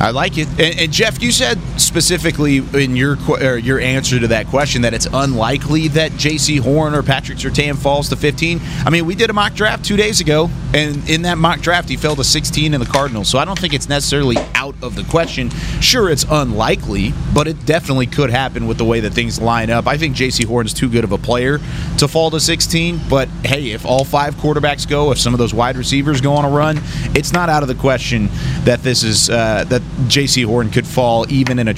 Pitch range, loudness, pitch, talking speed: 125-155 Hz, -15 LUFS, 140 Hz, 235 wpm